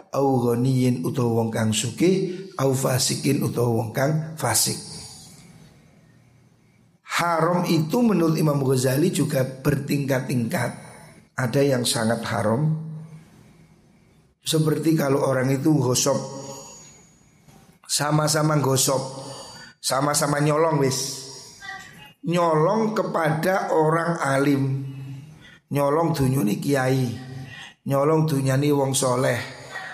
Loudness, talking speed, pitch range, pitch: -22 LUFS, 75 wpm, 130-160 Hz, 140 Hz